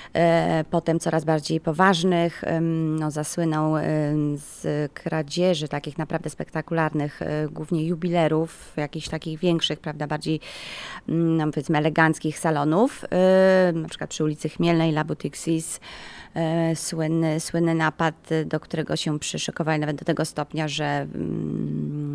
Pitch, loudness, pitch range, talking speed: 160 Hz, -24 LUFS, 150-165 Hz, 110 wpm